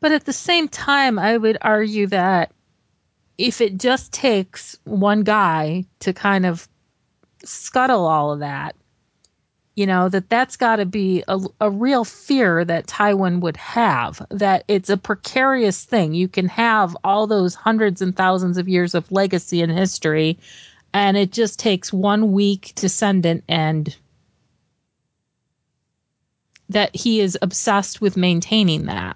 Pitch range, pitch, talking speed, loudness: 180-215 Hz, 195 Hz, 145 wpm, -19 LUFS